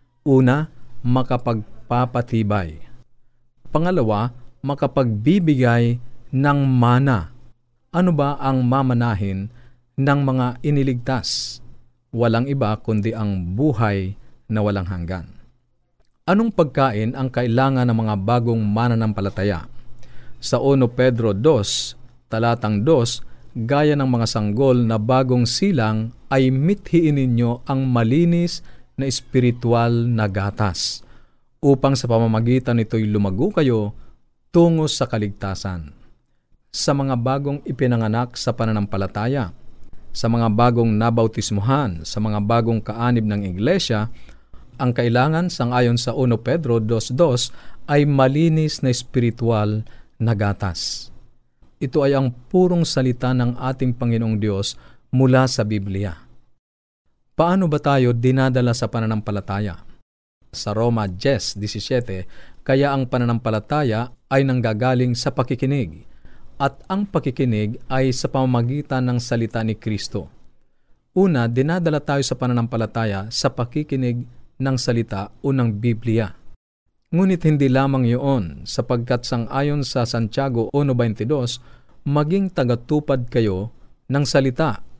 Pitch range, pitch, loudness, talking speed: 110-135 Hz, 120 Hz, -20 LUFS, 110 wpm